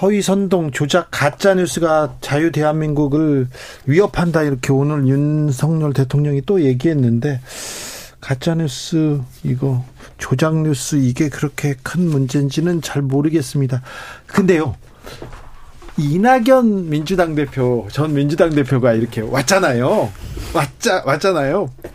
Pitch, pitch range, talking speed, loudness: 145 Hz, 135-165 Hz, 270 characters per minute, -17 LUFS